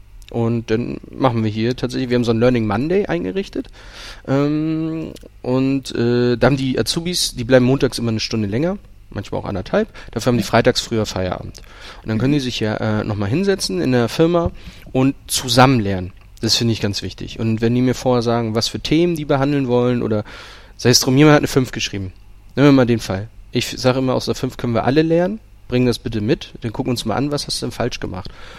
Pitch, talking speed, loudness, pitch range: 120 Hz, 230 wpm, -18 LUFS, 110-135 Hz